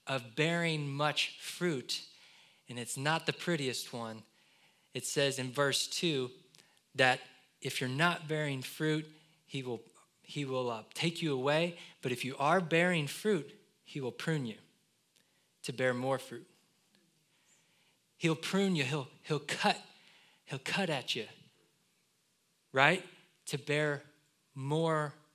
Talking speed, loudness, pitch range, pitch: 135 wpm, -34 LUFS, 135-170 Hz, 150 Hz